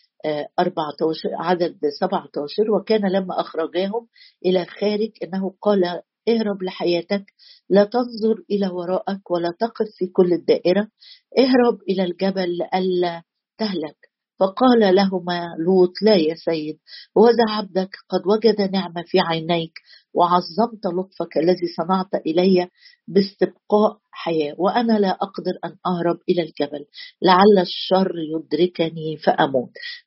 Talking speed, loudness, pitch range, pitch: 115 wpm, -20 LUFS, 175-210 Hz, 185 Hz